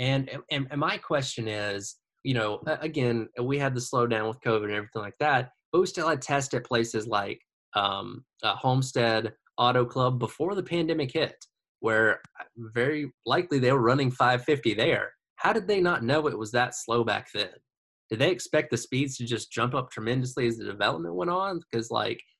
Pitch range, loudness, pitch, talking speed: 115-150 Hz, -27 LUFS, 125 Hz, 195 wpm